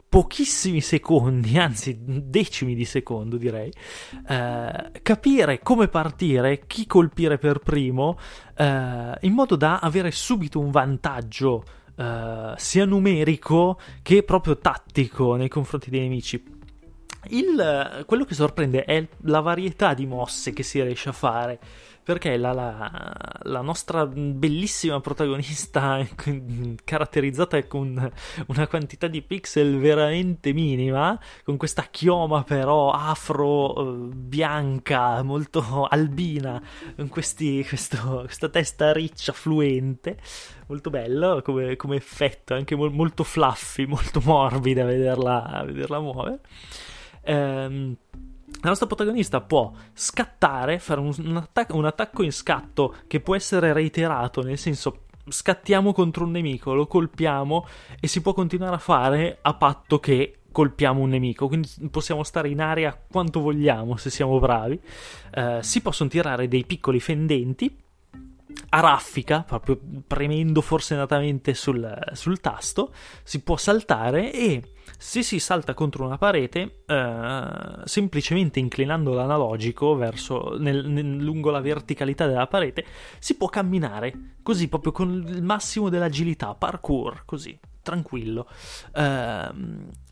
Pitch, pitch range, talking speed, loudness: 150 Hz, 130-165 Hz, 125 wpm, -24 LUFS